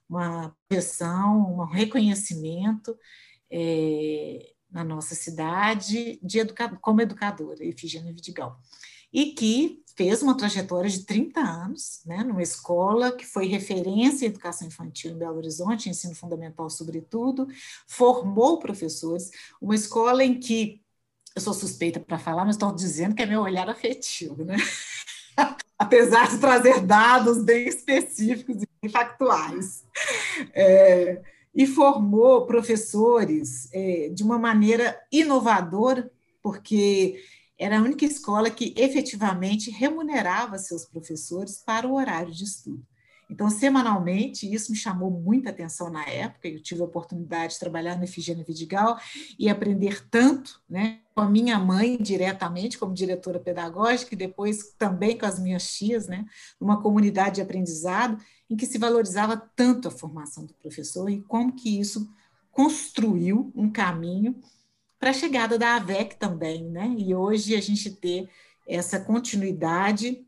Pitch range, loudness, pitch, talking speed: 175-235 Hz, -24 LUFS, 205 Hz, 140 wpm